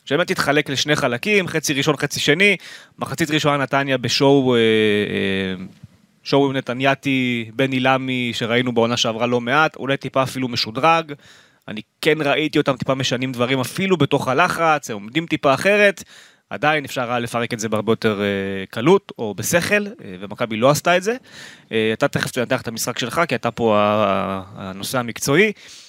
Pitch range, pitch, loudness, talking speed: 115-150 Hz, 130 Hz, -19 LUFS, 150 wpm